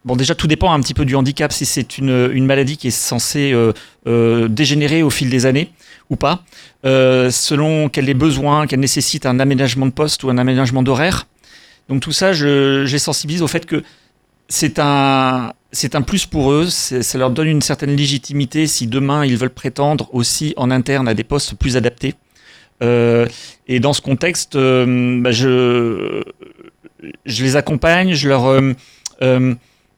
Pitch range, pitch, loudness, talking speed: 125-150 Hz, 135 Hz, -15 LUFS, 185 wpm